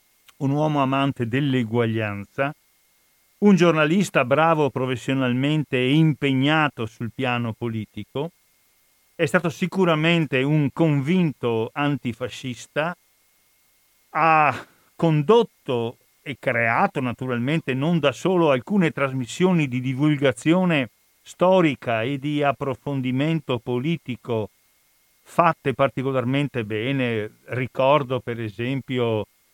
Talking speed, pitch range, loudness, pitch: 85 wpm, 125-155 Hz, -22 LUFS, 135 Hz